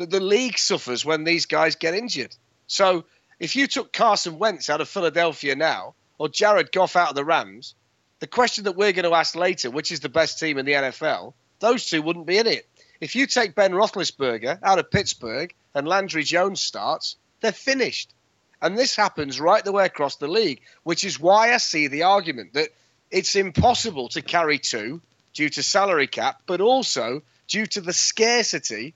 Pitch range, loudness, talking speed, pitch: 150-210 Hz, -22 LUFS, 195 wpm, 170 Hz